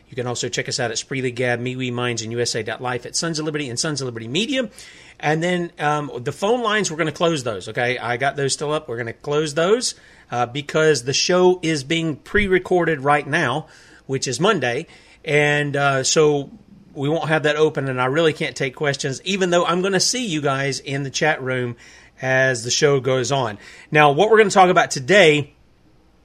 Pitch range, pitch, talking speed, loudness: 130-165 Hz, 150 Hz, 220 wpm, -19 LUFS